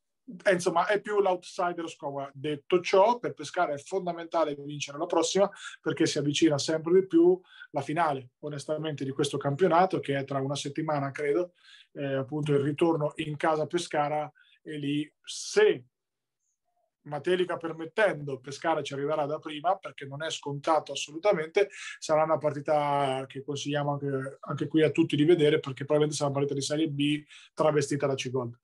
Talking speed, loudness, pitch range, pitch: 160 wpm, -28 LUFS, 145-175 Hz, 150 Hz